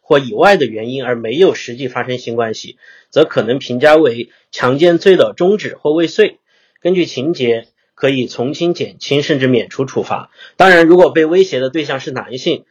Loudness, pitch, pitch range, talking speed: -13 LUFS, 150 Hz, 125-175 Hz, 285 characters per minute